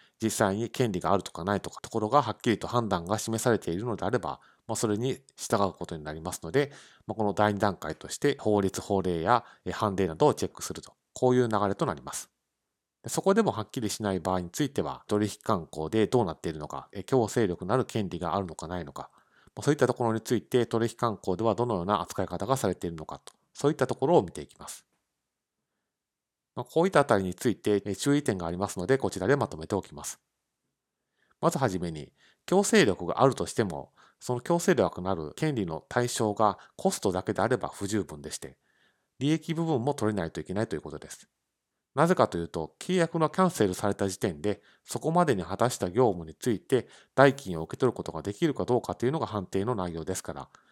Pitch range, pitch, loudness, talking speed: 90-125 Hz, 105 Hz, -29 LUFS, 425 characters per minute